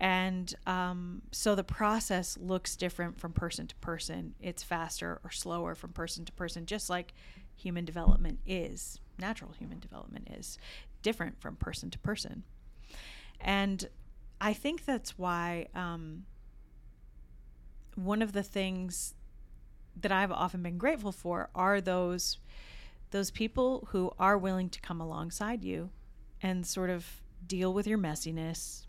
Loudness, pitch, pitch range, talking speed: -35 LUFS, 180 Hz, 170-195 Hz, 140 wpm